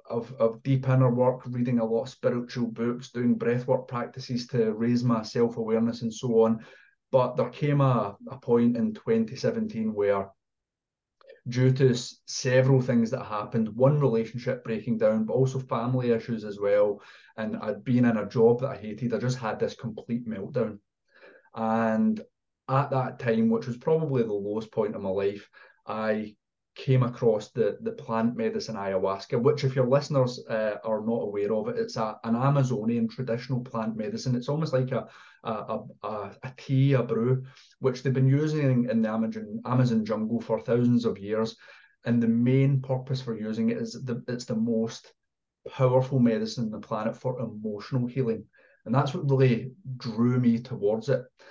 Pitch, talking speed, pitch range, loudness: 120 Hz, 175 wpm, 115-130 Hz, -27 LUFS